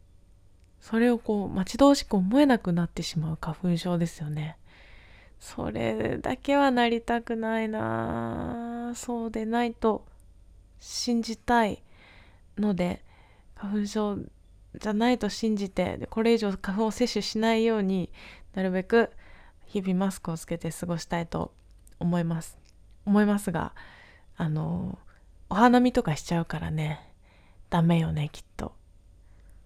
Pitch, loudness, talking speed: 175 Hz, -27 LUFS, 260 characters per minute